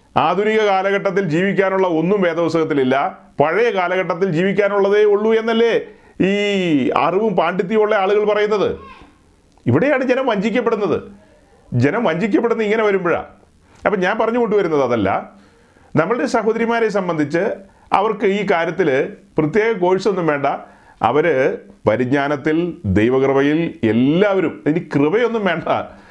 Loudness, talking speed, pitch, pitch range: -17 LUFS, 100 wpm, 200 Hz, 165-220 Hz